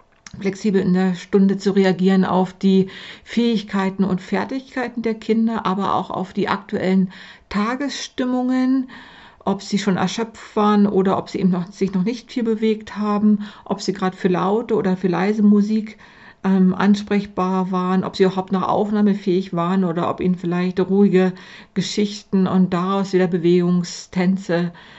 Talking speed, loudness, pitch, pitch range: 150 wpm, -20 LUFS, 195 Hz, 185-210 Hz